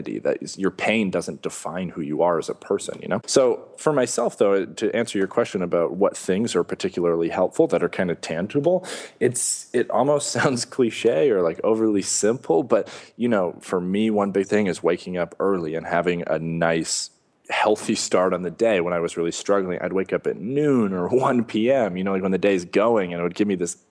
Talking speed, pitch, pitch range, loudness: 225 wpm, 95 Hz, 90-115 Hz, -22 LUFS